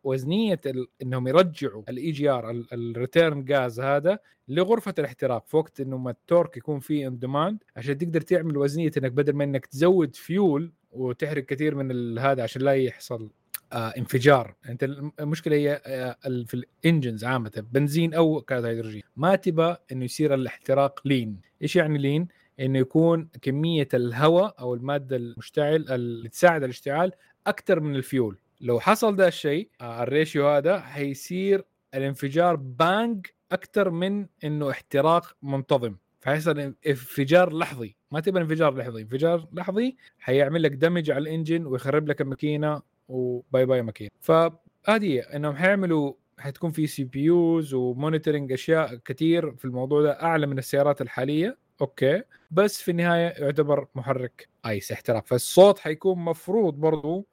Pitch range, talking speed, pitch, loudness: 130-165 Hz, 140 wpm, 145 Hz, -25 LUFS